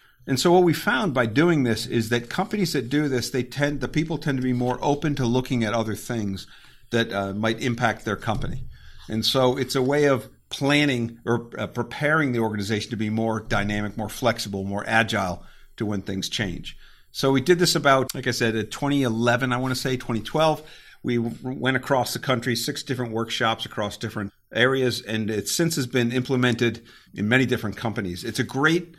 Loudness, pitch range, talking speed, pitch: -24 LUFS, 110-135 Hz, 200 wpm, 120 Hz